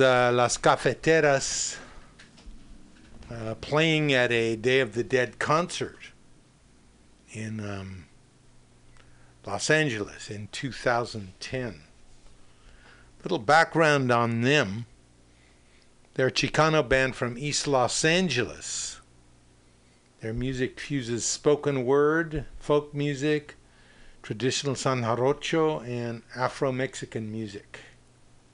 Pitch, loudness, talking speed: 120 Hz, -26 LUFS, 95 wpm